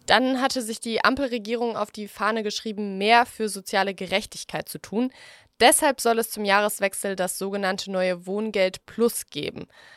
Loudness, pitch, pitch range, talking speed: -24 LUFS, 210 Hz, 195-235 Hz, 155 wpm